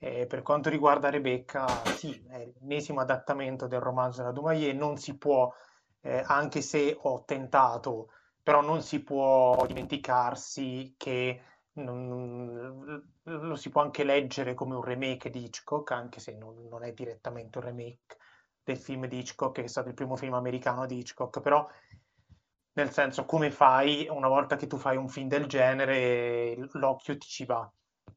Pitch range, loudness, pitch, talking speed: 125-145 Hz, -30 LUFS, 130 Hz, 170 wpm